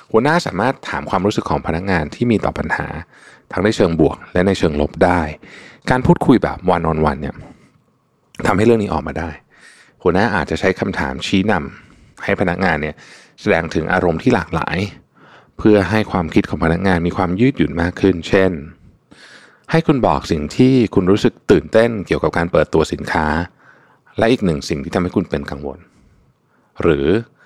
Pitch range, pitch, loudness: 80-100 Hz, 90 Hz, -17 LUFS